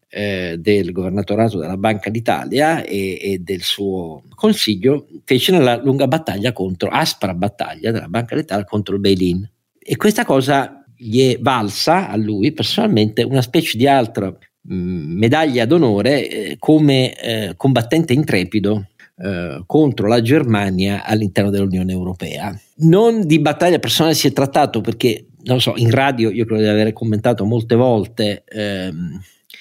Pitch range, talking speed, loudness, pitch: 100-135 Hz, 145 wpm, -16 LUFS, 110 Hz